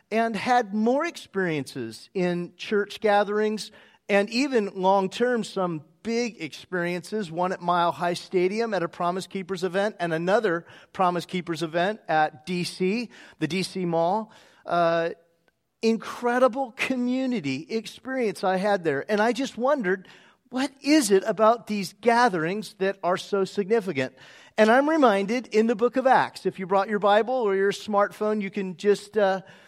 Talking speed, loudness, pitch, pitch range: 150 wpm, -25 LUFS, 200 Hz, 180-225 Hz